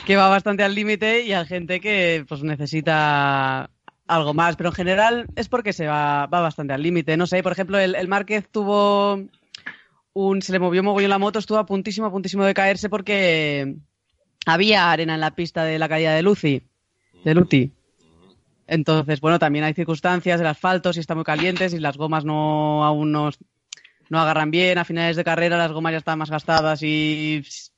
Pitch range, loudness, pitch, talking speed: 155-195 Hz, -20 LUFS, 170 Hz, 200 wpm